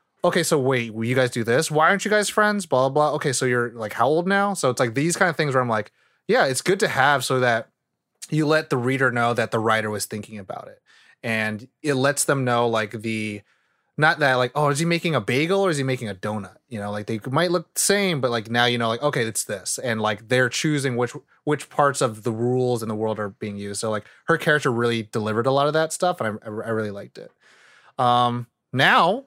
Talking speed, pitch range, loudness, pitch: 260 wpm, 110-150 Hz, -22 LUFS, 125 Hz